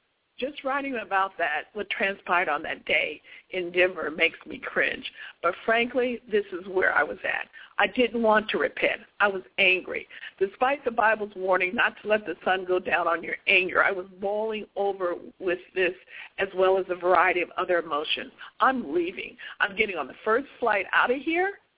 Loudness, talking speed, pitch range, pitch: -25 LUFS, 190 wpm, 180-240 Hz, 200 Hz